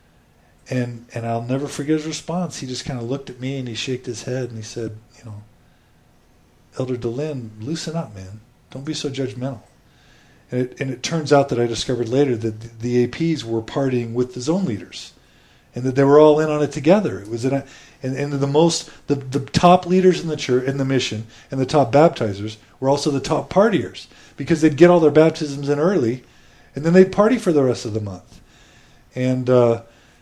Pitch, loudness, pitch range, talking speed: 135 Hz, -20 LUFS, 120-150 Hz, 215 wpm